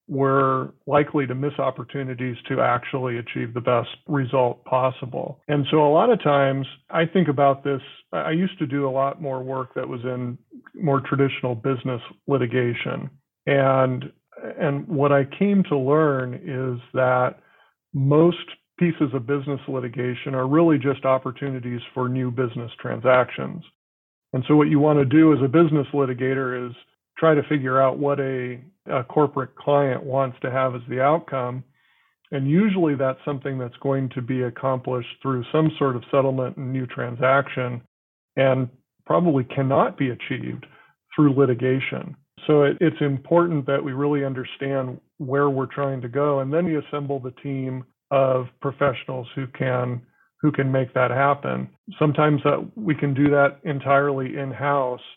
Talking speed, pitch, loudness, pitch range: 160 wpm, 135 Hz, -22 LUFS, 130-145 Hz